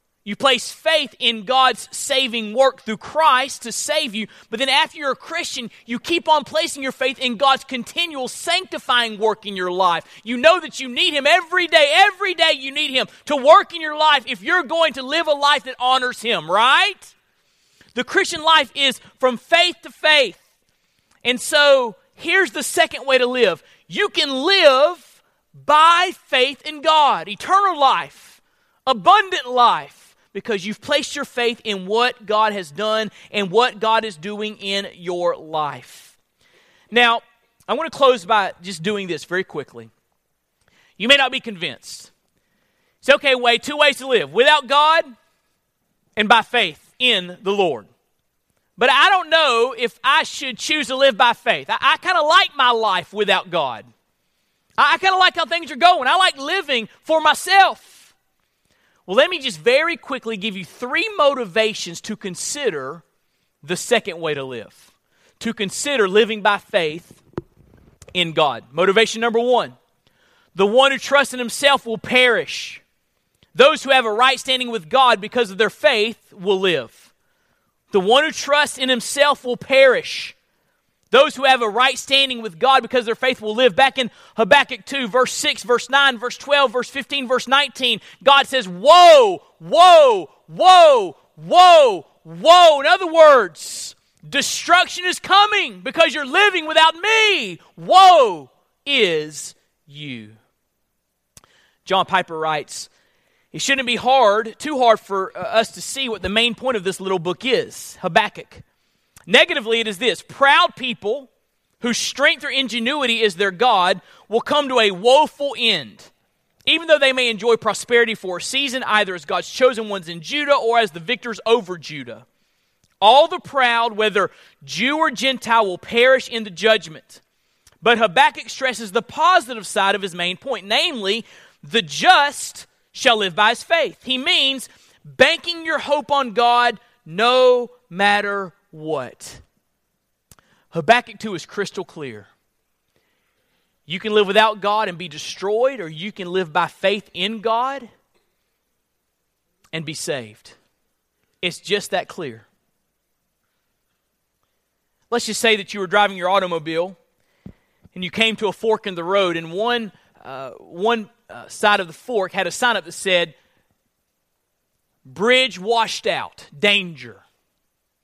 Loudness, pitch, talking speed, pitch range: -17 LUFS, 245 Hz, 160 wpm, 205-290 Hz